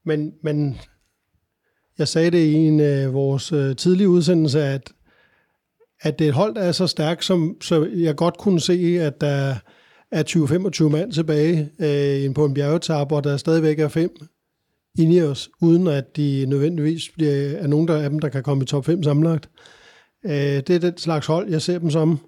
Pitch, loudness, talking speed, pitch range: 155 Hz, -20 LUFS, 190 wpm, 145-170 Hz